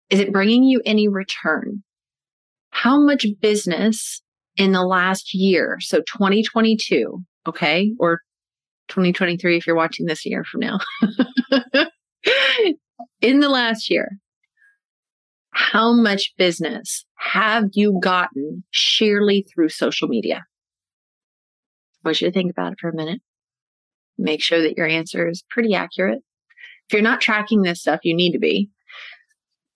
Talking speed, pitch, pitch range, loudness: 135 wpm, 205 Hz, 180-235 Hz, -19 LUFS